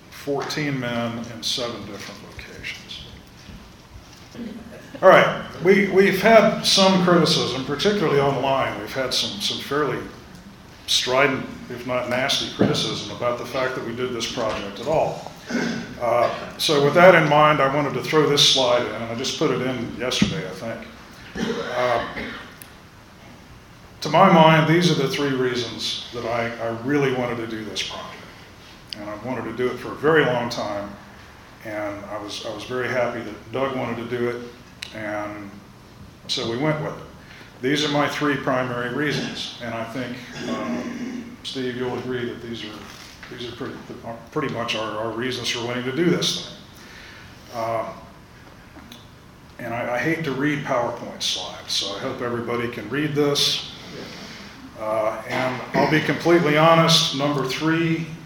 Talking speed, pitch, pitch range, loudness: 165 wpm, 125 Hz, 115-150 Hz, -21 LUFS